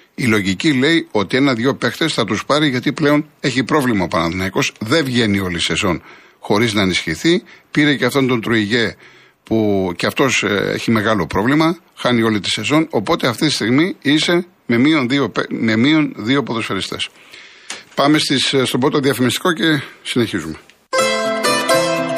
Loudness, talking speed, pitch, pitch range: -16 LUFS, 150 wpm, 130 Hz, 110-155 Hz